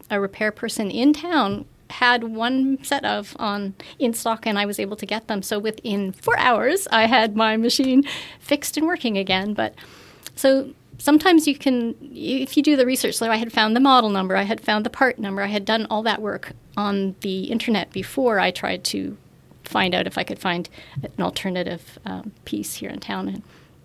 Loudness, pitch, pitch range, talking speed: -21 LUFS, 225 Hz, 205-265 Hz, 205 wpm